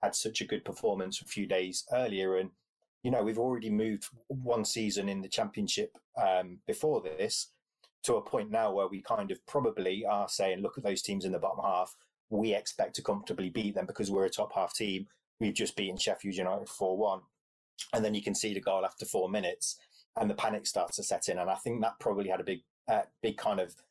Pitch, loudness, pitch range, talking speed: 110 Hz, -33 LUFS, 100-125 Hz, 225 wpm